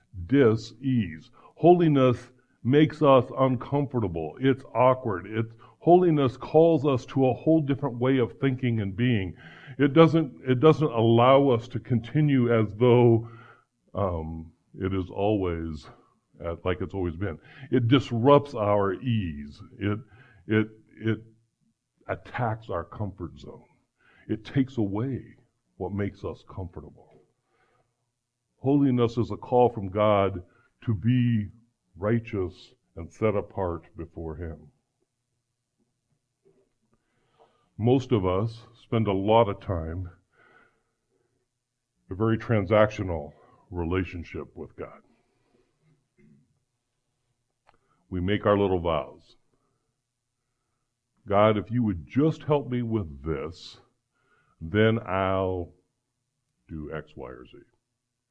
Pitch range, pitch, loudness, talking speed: 95-125 Hz, 115 Hz, -25 LUFS, 110 wpm